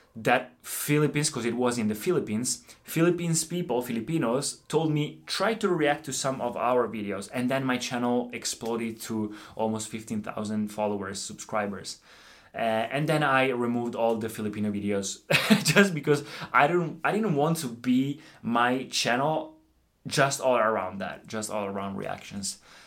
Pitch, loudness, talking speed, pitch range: 120 Hz, -27 LUFS, 155 wpm, 110-150 Hz